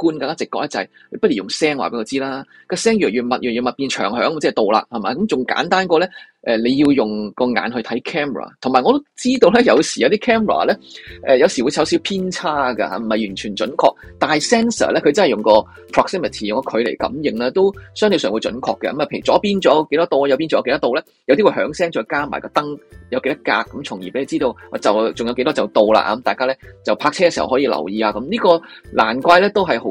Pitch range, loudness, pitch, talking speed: 125-185 Hz, -17 LUFS, 140 Hz, 405 characters per minute